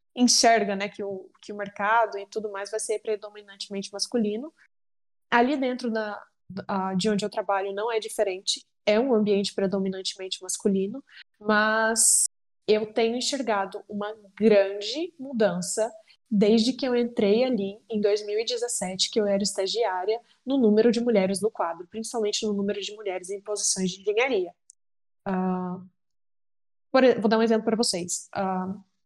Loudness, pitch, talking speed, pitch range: -25 LUFS, 210 Hz, 145 wpm, 195-230 Hz